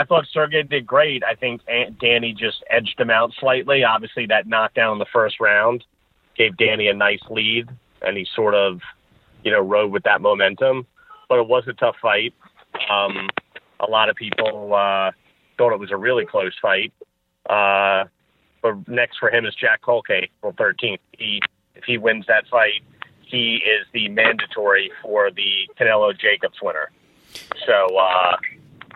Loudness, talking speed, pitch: -19 LUFS, 170 wpm, 120 Hz